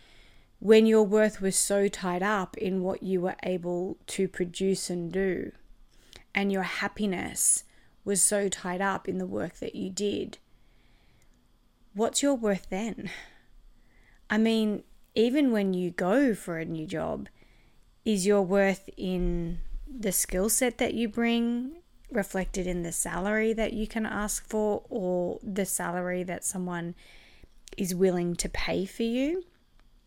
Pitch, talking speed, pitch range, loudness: 195 Hz, 145 wpm, 180-220 Hz, -28 LUFS